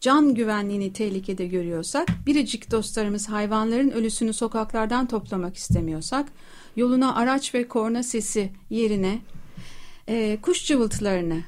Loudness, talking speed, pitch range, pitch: -24 LUFS, 105 wpm, 195-245 Hz, 220 Hz